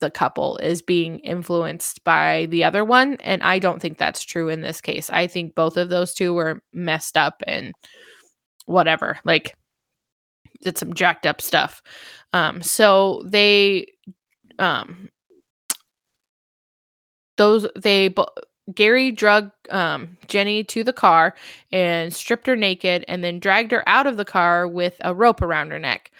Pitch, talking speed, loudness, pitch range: 190 Hz, 150 wpm, -19 LUFS, 175-210 Hz